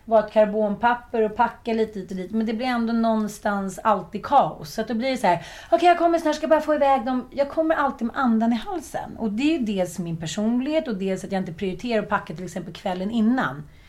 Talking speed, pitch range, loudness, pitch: 250 wpm, 200-260 Hz, -23 LUFS, 225 Hz